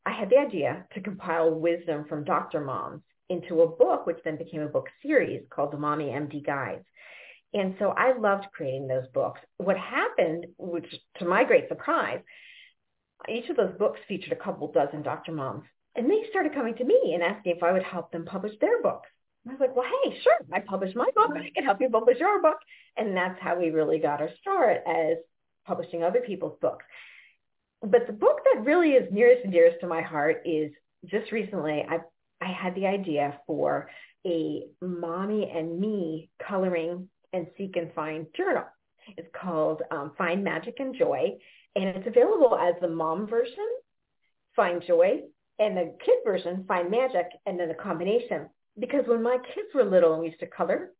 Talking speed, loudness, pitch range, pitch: 190 wpm, -27 LUFS, 170-270 Hz, 190 Hz